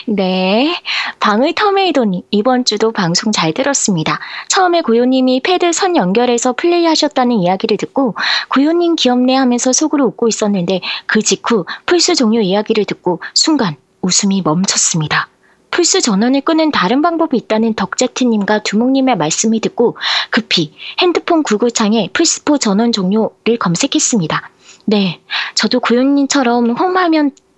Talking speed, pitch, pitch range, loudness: 325 characters per minute, 240 Hz, 210-295 Hz, -13 LUFS